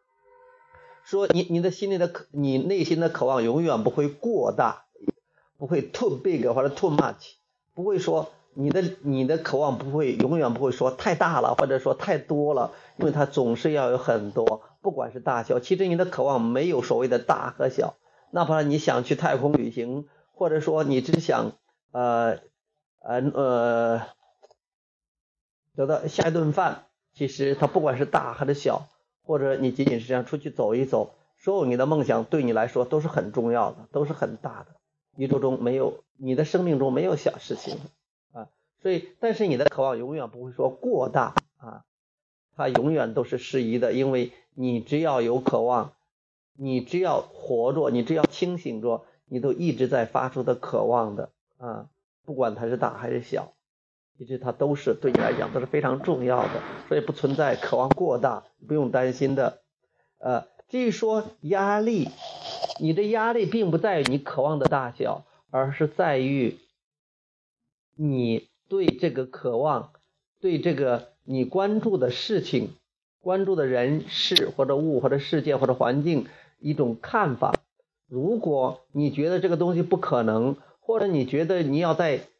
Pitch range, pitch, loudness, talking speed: 130-180 Hz, 145 Hz, -25 LUFS, 250 characters per minute